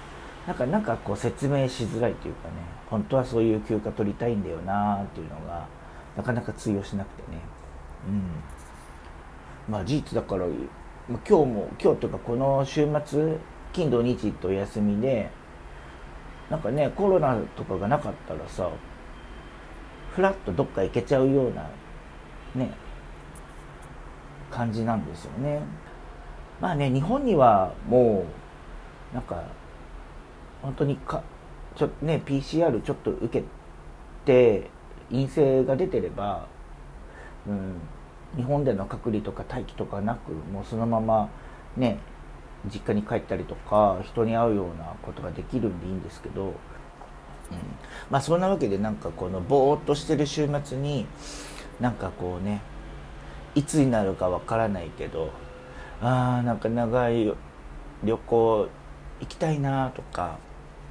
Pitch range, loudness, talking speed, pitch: 80-125 Hz, -27 LUFS, 265 characters per minute, 105 Hz